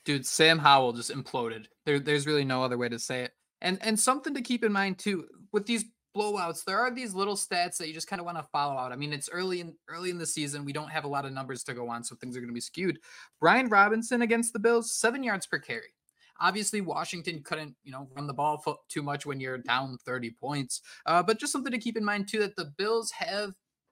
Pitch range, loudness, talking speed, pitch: 140-210 Hz, -29 LUFS, 255 wpm, 170 Hz